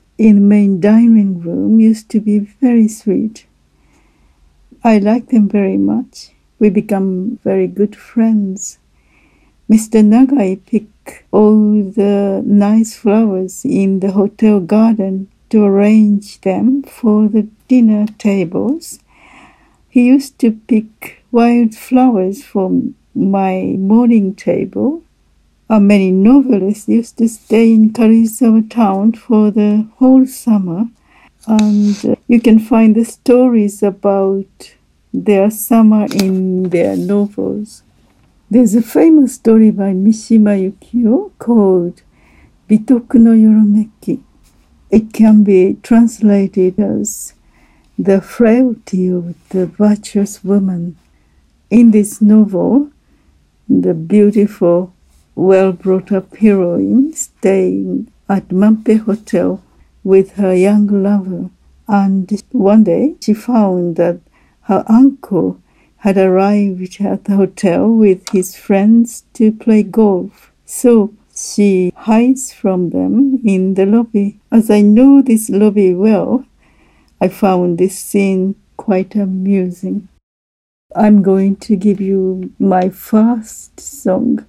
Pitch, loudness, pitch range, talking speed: 210 Hz, -12 LUFS, 190-225 Hz, 115 wpm